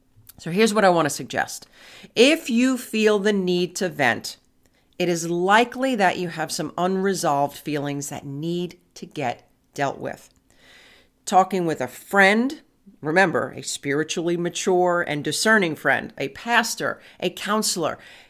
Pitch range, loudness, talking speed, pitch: 150-210 Hz, -22 LUFS, 145 wpm, 180 Hz